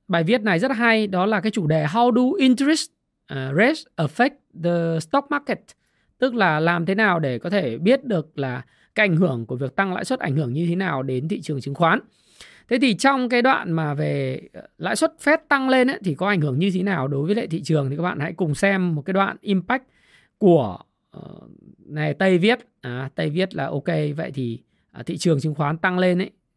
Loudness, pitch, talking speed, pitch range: -21 LUFS, 185 Hz, 225 wpm, 155-230 Hz